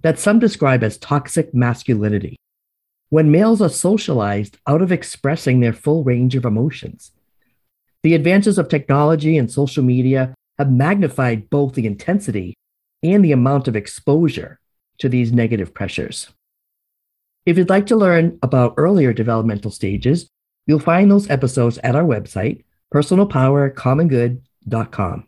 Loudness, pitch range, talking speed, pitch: -17 LUFS, 120-165 Hz, 135 wpm, 140 Hz